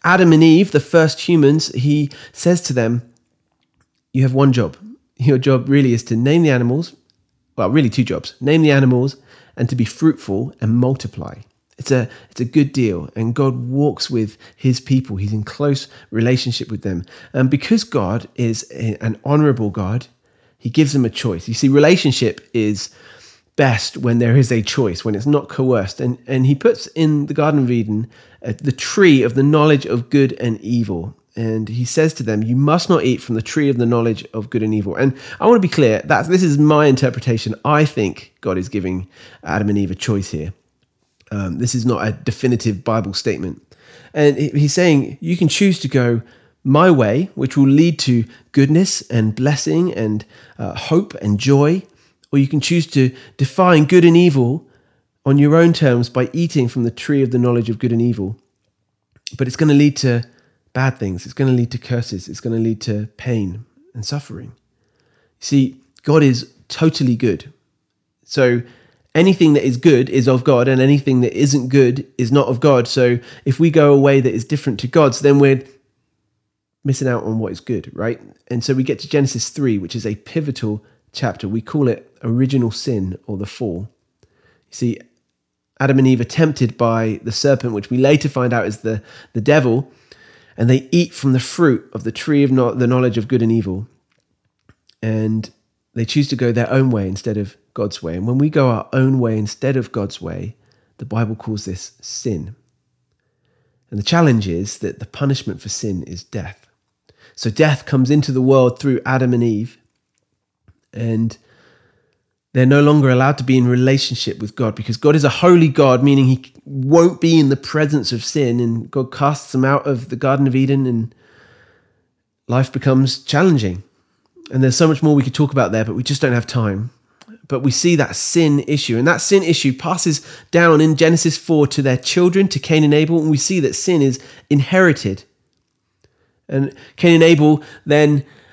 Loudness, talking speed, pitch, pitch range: -16 LUFS, 195 wpm, 130 Hz, 115-145 Hz